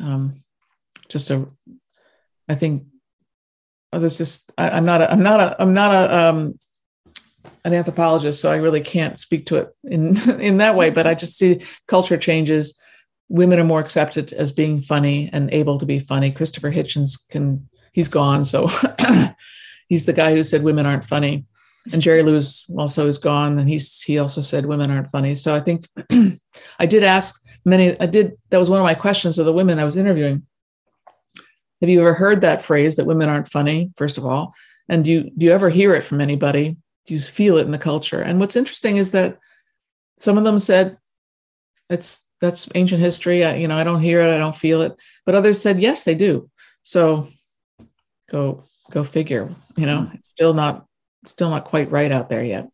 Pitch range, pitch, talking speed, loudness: 145-175 Hz, 160 Hz, 200 wpm, -18 LUFS